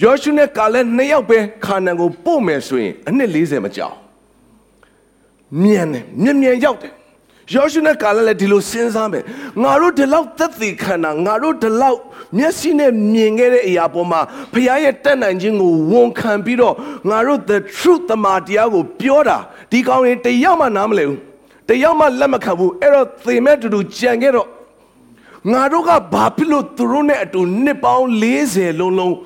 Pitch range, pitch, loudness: 205-285 Hz, 245 Hz, -14 LUFS